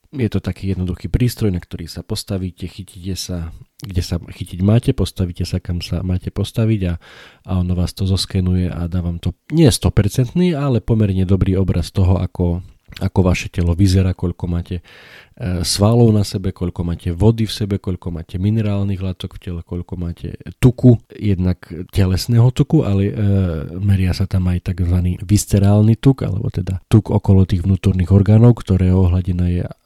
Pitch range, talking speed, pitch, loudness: 90-105 Hz, 170 wpm, 95 Hz, -17 LUFS